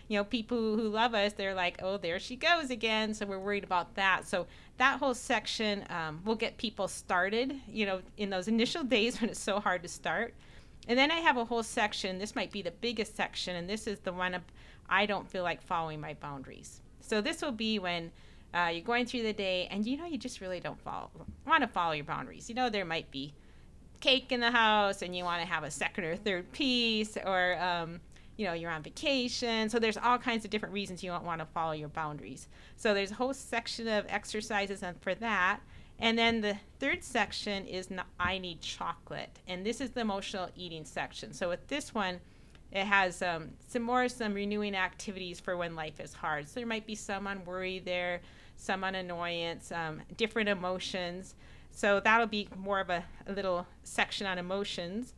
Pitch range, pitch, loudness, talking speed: 180-230 Hz, 200 Hz, -33 LUFS, 215 wpm